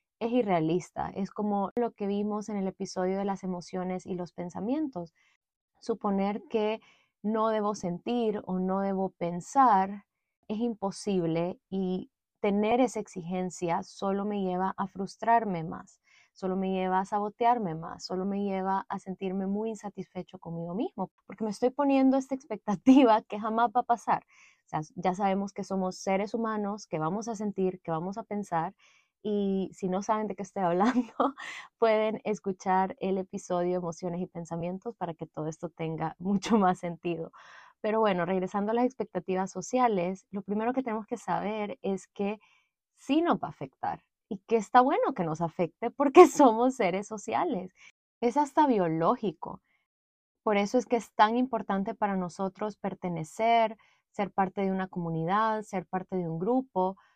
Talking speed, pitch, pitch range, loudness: 165 wpm, 200 Hz, 185-220 Hz, -29 LUFS